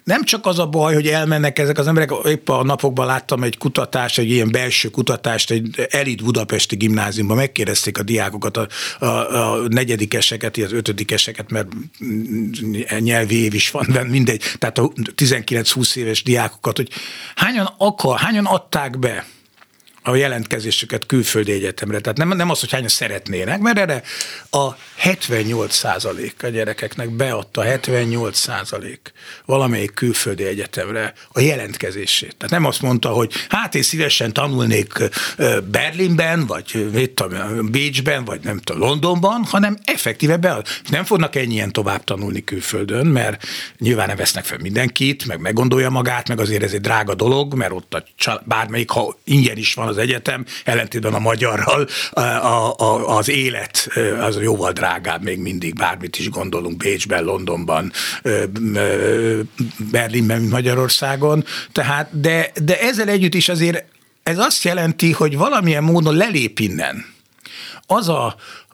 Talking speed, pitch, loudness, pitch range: 140 wpm, 120 Hz, -18 LUFS, 110-145 Hz